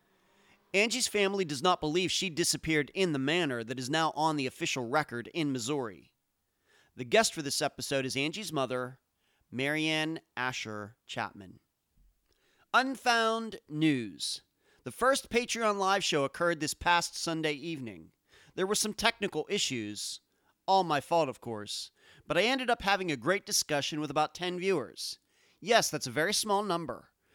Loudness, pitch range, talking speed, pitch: -30 LUFS, 135-195 Hz, 155 wpm, 160 Hz